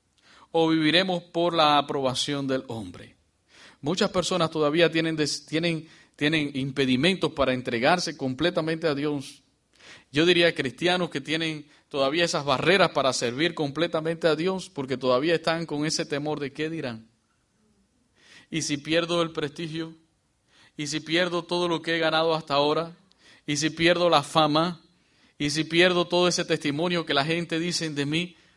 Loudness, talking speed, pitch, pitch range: -25 LUFS, 155 wpm, 160 Hz, 145-170 Hz